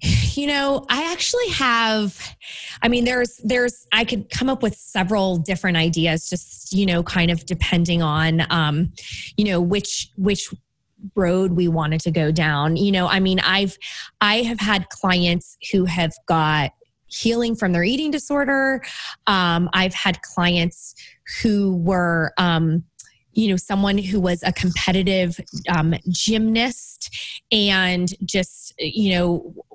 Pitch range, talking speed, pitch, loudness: 175-215 Hz, 145 wpm, 185 Hz, -20 LUFS